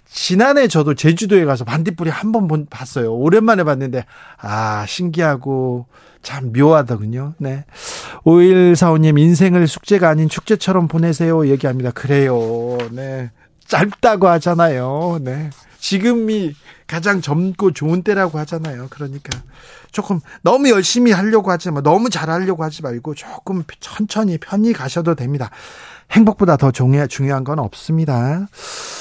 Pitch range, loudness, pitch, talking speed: 135-190 Hz, -15 LUFS, 160 Hz, 310 characters per minute